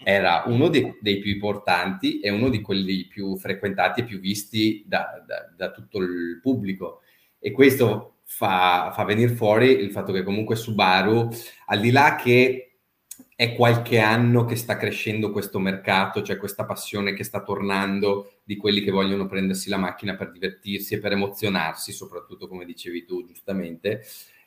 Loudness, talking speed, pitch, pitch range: -23 LUFS, 165 wpm, 105 Hz, 100-120 Hz